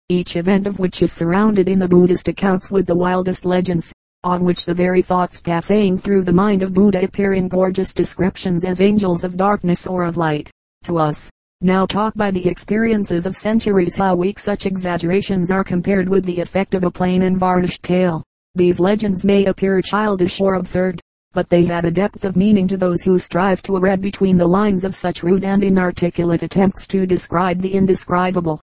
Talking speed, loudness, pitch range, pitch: 195 wpm, -17 LUFS, 180-195 Hz, 185 Hz